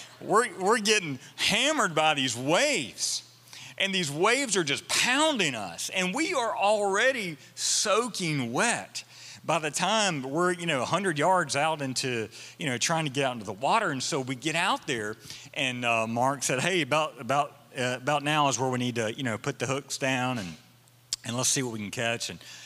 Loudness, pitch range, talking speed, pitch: -27 LUFS, 125-180 Hz, 200 wpm, 140 Hz